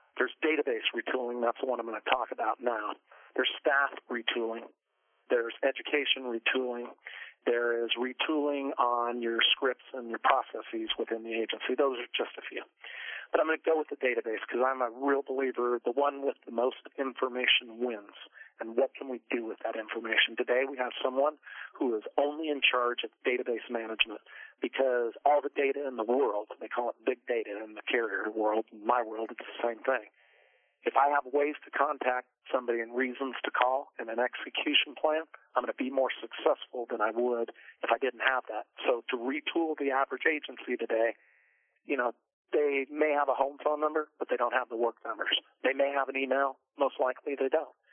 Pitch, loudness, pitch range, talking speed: 130 Hz, -31 LUFS, 120-145 Hz, 200 wpm